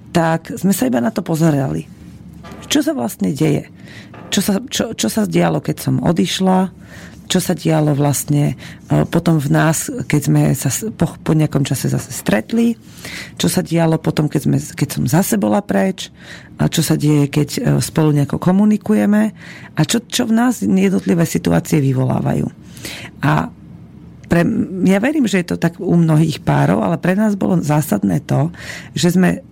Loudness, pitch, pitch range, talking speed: -16 LUFS, 165 Hz, 150-195 Hz, 165 wpm